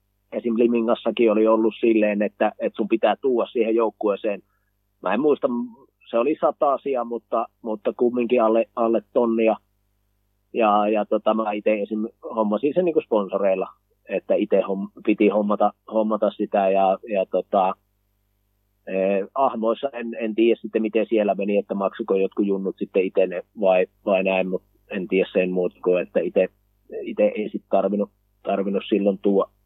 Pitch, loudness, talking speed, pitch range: 105 Hz, -22 LUFS, 150 wpm, 100-115 Hz